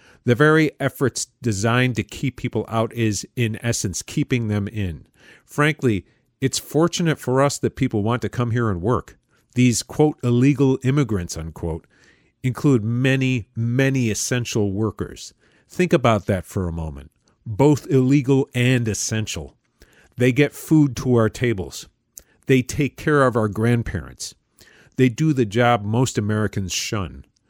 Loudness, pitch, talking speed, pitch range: -21 LUFS, 120 Hz, 145 wpm, 105-135 Hz